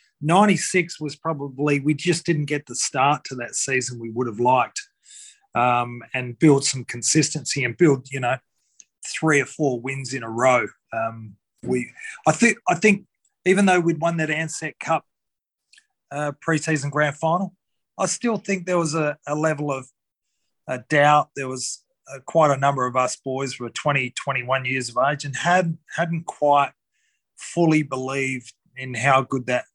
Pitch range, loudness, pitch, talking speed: 130-165 Hz, -22 LUFS, 145 Hz, 175 wpm